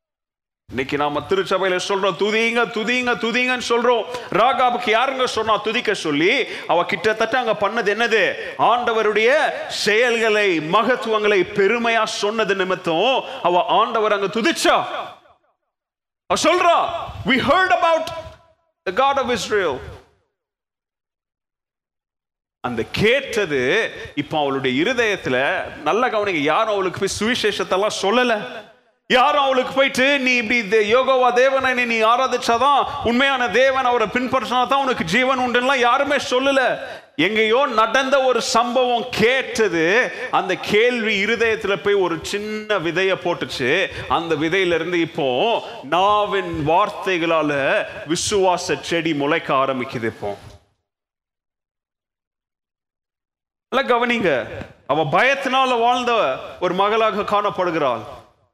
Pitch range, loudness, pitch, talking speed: 190-255 Hz, -18 LUFS, 220 Hz, 100 wpm